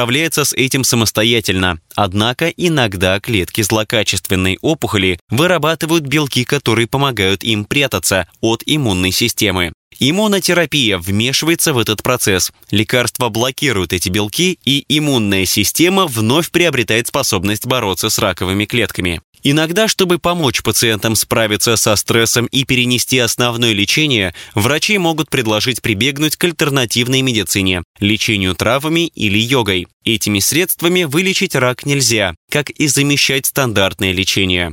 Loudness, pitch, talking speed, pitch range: -14 LUFS, 120 Hz, 120 wpm, 105-145 Hz